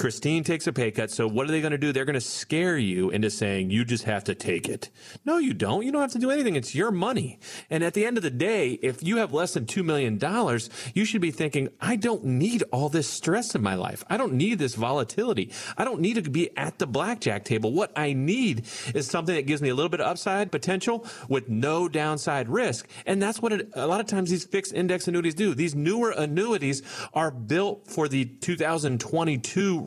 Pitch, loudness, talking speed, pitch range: 160 Hz, -26 LUFS, 235 wpm, 130-195 Hz